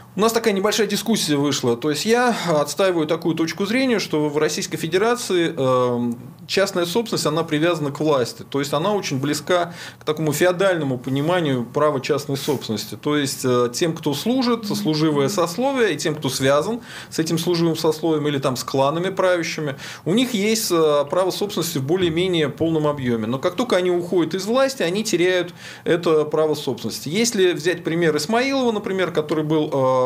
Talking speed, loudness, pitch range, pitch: 165 wpm, -20 LUFS, 145-185 Hz, 165 Hz